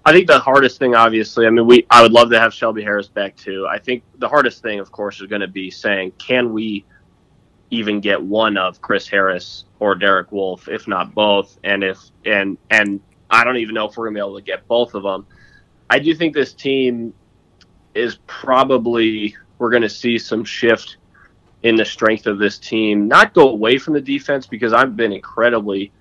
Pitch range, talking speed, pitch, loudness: 100-120 Hz, 210 wpm, 110 Hz, -15 LUFS